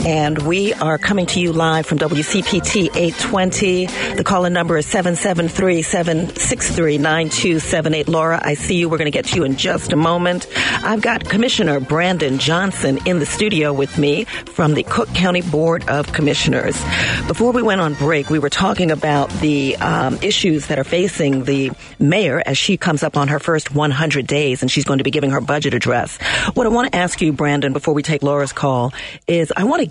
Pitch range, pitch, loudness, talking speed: 150-180 Hz, 160 Hz, -17 LUFS, 195 wpm